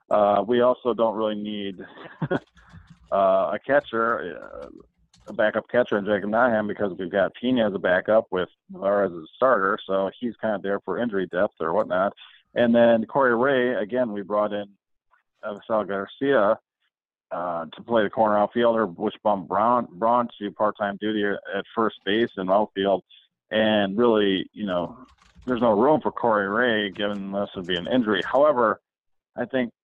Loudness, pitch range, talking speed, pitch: -23 LUFS, 100-115 Hz, 170 wpm, 105 Hz